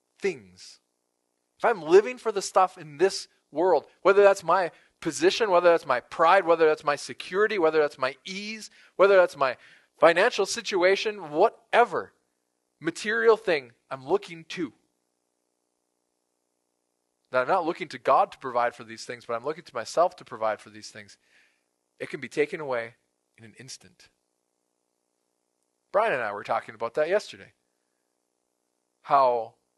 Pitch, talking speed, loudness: 120 Hz, 150 wpm, -25 LUFS